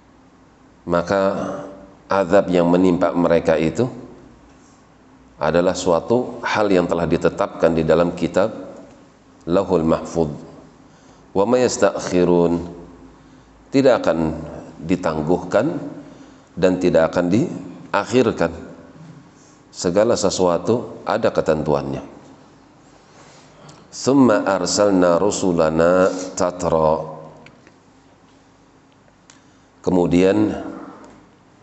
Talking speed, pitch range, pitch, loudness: 65 wpm, 85-95 Hz, 90 Hz, -18 LUFS